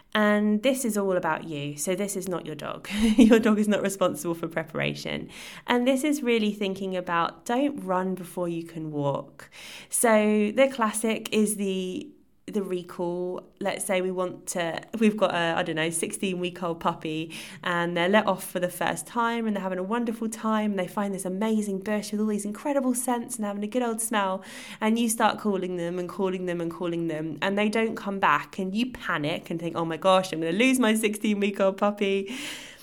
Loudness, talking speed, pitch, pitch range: -26 LUFS, 215 wpm, 195 Hz, 175-220 Hz